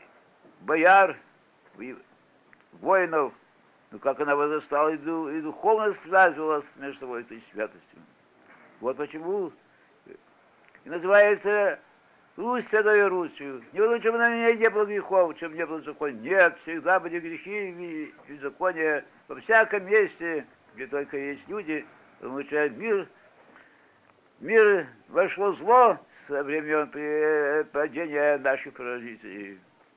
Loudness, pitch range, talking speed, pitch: -25 LUFS, 145-205 Hz, 110 wpm, 165 Hz